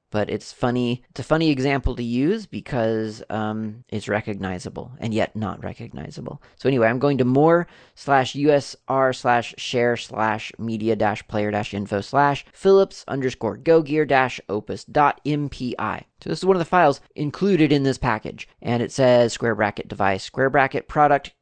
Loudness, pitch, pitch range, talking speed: -22 LUFS, 125 Hz, 110-140 Hz, 175 wpm